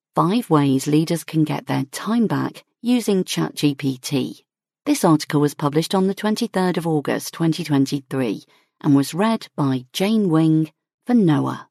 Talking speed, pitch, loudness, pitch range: 145 wpm, 160 Hz, -20 LUFS, 145-195 Hz